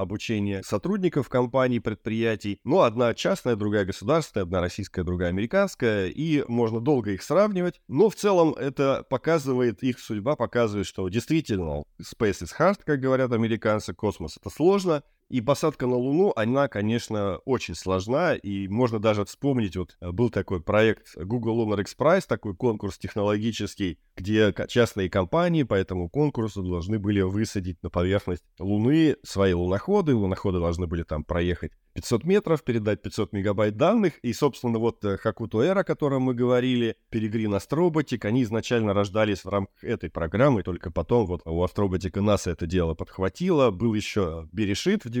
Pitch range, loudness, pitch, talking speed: 95-130 Hz, -25 LUFS, 110 Hz, 155 wpm